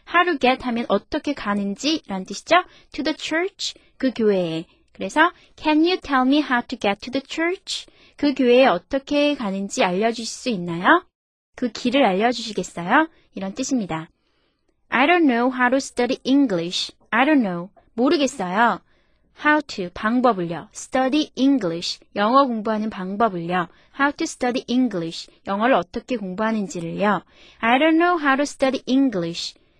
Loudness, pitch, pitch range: -21 LUFS, 250 Hz, 200-280 Hz